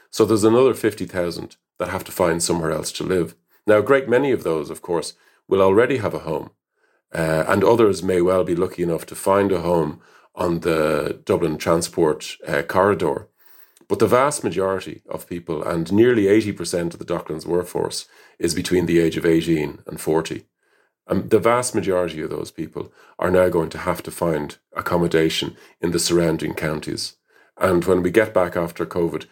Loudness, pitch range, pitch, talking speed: -20 LUFS, 85-95 Hz, 90 Hz, 185 wpm